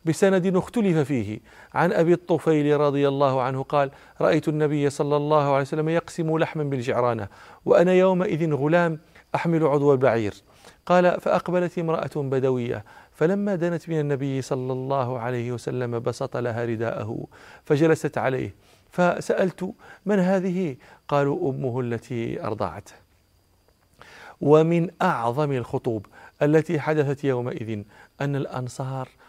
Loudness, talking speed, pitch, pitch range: -23 LUFS, 115 wpm, 145 Hz, 125-165 Hz